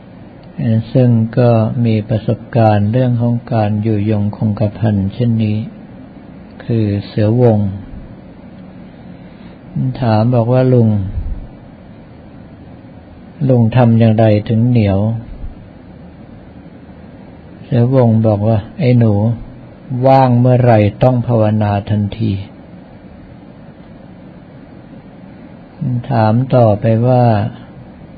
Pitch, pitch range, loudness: 110 Hz, 105-120 Hz, -13 LUFS